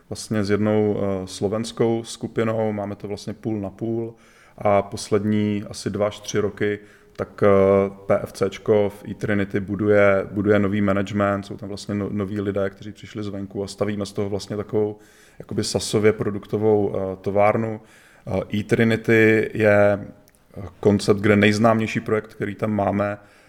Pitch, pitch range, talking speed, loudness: 105 Hz, 100-110 Hz, 155 wpm, -22 LUFS